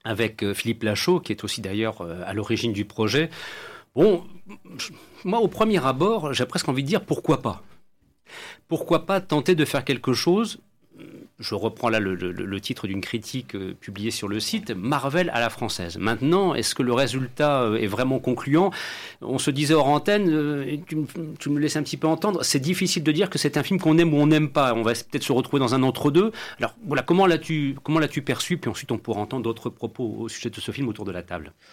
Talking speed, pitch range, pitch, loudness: 215 wpm, 115-160 Hz, 135 Hz, -24 LUFS